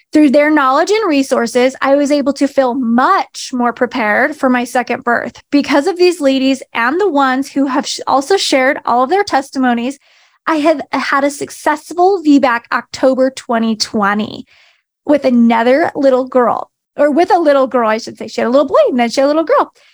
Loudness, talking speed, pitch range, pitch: -13 LUFS, 195 wpm, 250-295 Hz, 270 Hz